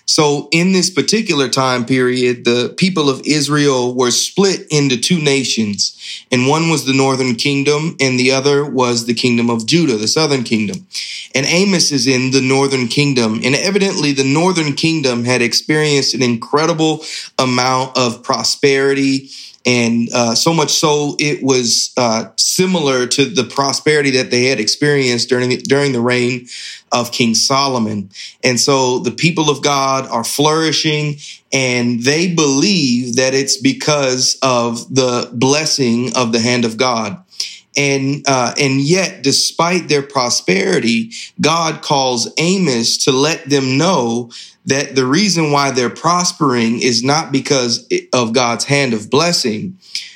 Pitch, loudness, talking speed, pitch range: 135 Hz, -14 LUFS, 150 wpm, 125-150 Hz